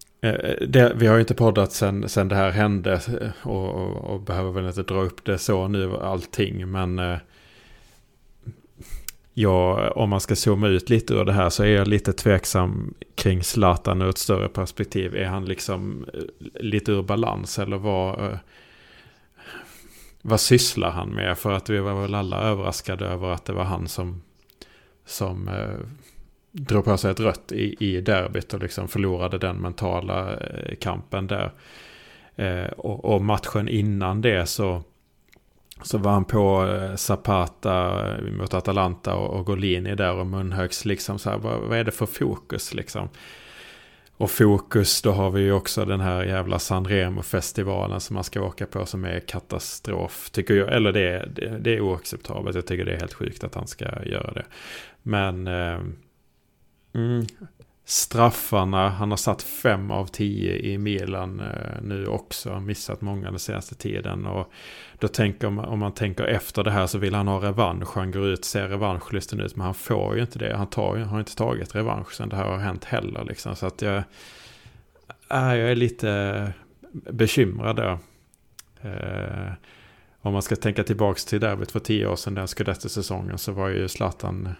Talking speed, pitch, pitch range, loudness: 175 wpm, 100 Hz, 95-105 Hz, -24 LUFS